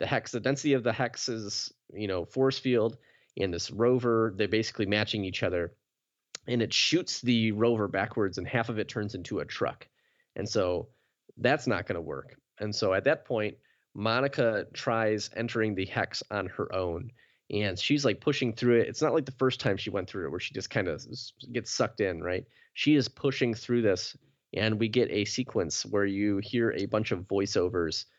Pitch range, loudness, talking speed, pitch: 105-125 Hz, -29 LUFS, 200 wpm, 115 Hz